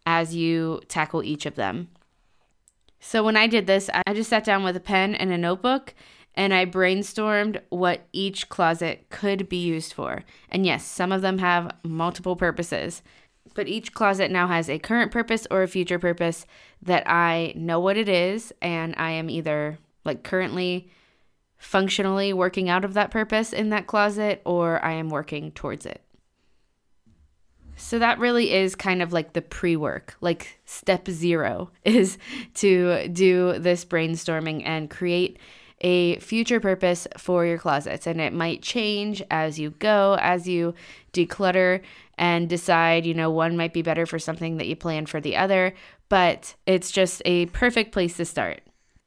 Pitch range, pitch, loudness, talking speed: 165-195 Hz, 180 Hz, -24 LUFS, 170 wpm